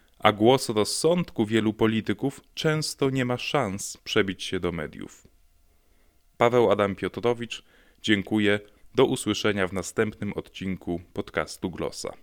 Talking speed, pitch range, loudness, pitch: 120 wpm, 95-120 Hz, -26 LUFS, 105 Hz